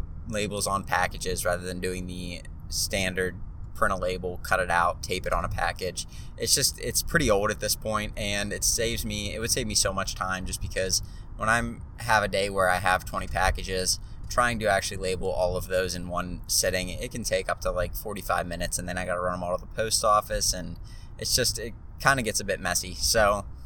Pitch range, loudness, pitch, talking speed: 90-105 Hz, -27 LUFS, 95 Hz, 230 wpm